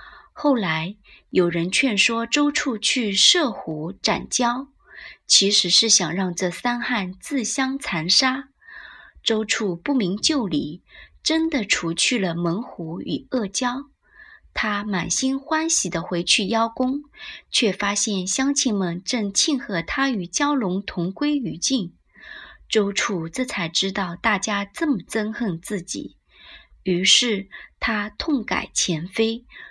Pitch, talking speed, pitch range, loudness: 220 Hz, 180 characters per minute, 185-265 Hz, -21 LUFS